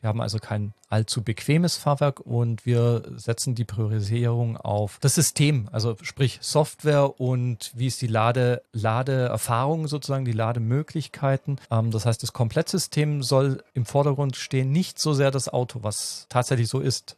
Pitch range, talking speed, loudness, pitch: 115-140 Hz, 155 wpm, -24 LUFS, 125 Hz